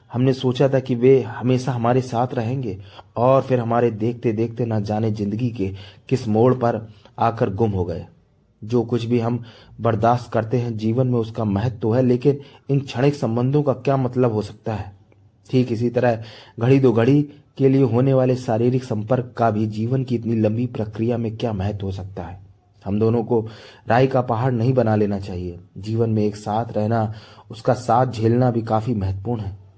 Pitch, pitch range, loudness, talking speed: 115 Hz, 110-125 Hz, -21 LUFS, 190 wpm